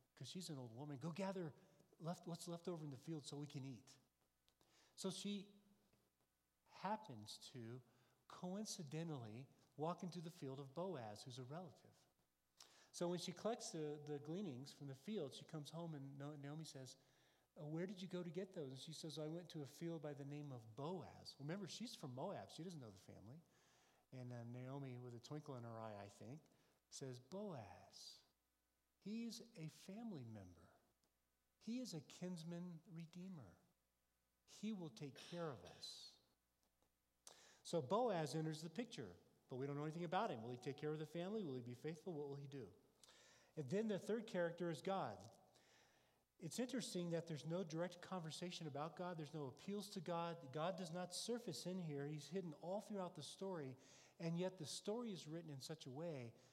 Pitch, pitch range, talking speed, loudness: 155 Hz, 130-180 Hz, 185 wpm, -51 LUFS